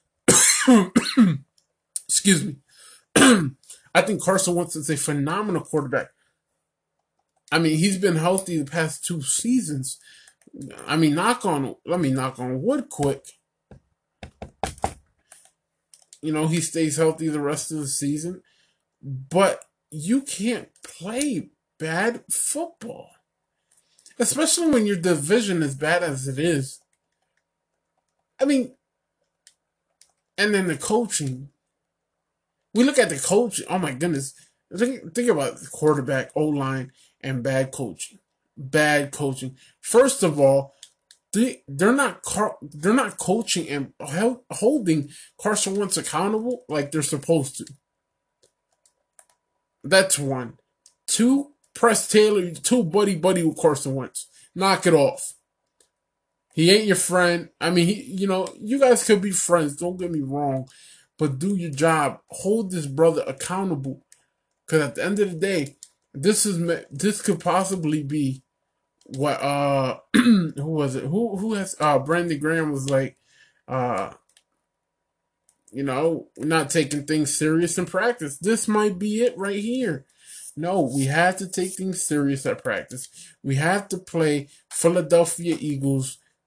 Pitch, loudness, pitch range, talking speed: 170 Hz, -22 LUFS, 145-200 Hz, 135 wpm